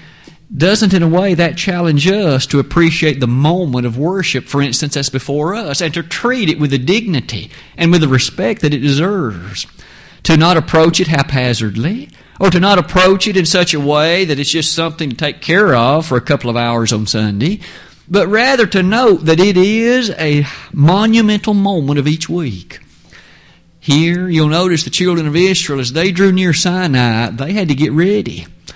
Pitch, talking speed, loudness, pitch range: 165 Hz, 190 wpm, -13 LUFS, 140-185 Hz